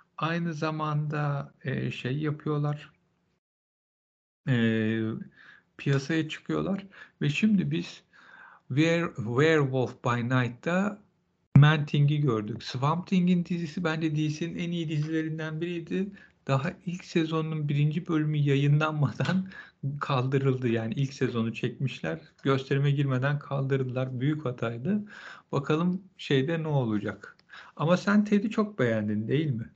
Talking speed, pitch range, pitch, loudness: 105 wpm, 130-170 Hz, 150 Hz, -28 LUFS